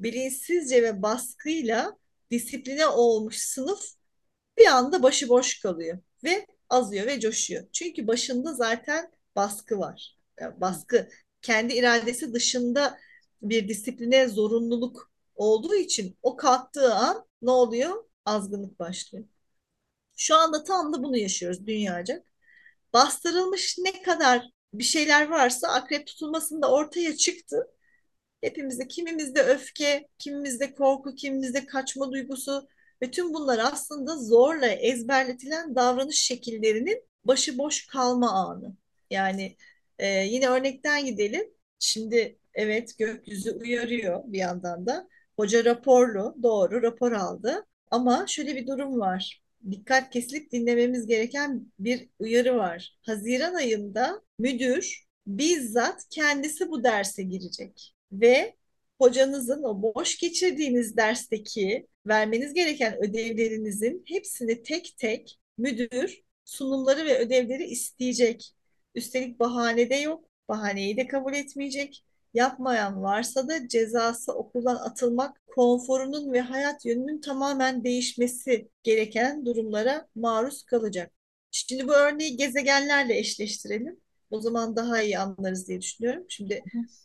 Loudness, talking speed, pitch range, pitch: -26 LUFS, 115 wpm, 230-285 Hz, 250 Hz